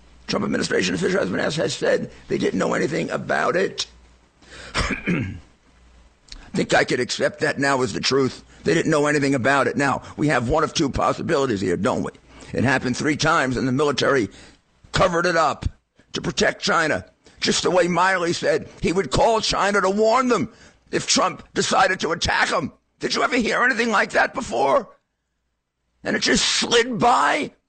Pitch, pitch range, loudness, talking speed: 140 Hz, 115-195 Hz, -21 LUFS, 180 wpm